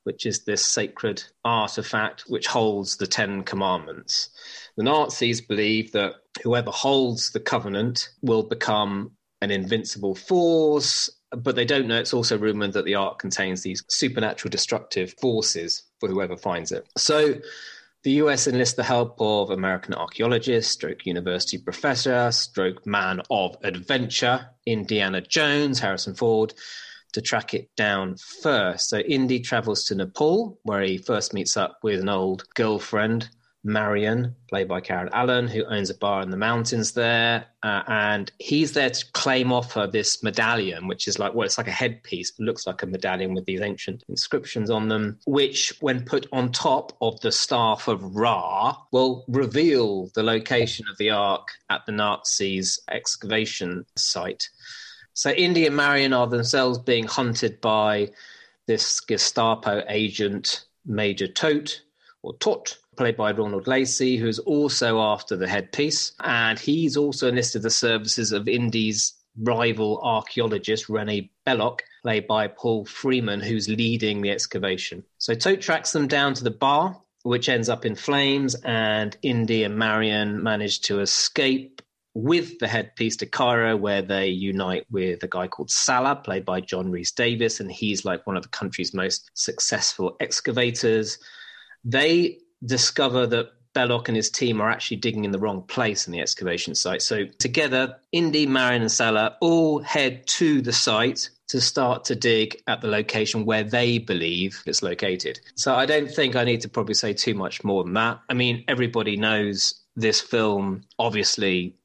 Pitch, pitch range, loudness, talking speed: 115 Hz, 105-130 Hz, -23 LUFS, 160 wpm